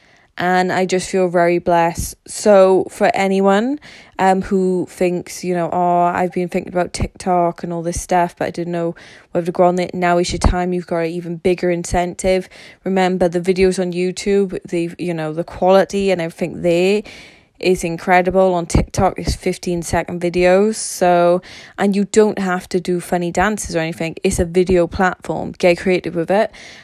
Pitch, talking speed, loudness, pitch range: 180 Hz, 185 wpm, -17 LUFS, 175-185 Hz